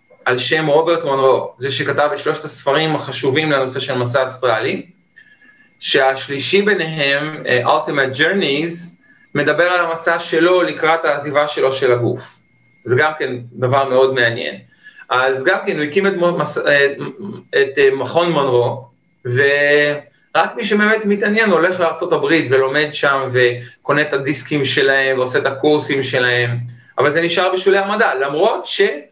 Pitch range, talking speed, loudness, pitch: 135-170 Hz, 135 wpm, -16 LUFS, 145 Hz